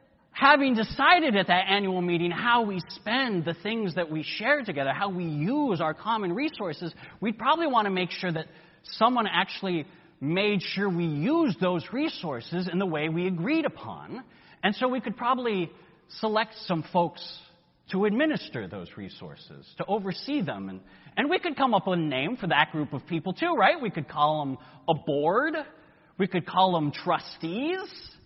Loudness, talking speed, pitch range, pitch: -27 LUFS, 180 wpm, 165-230 Hz, 185 Hz